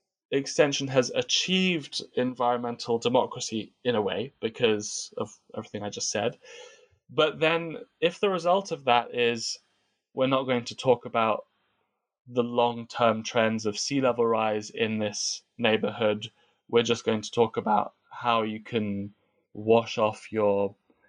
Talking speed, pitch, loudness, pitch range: 145 wpm, 120 Hz, -27 LUFS, 110-140 Hz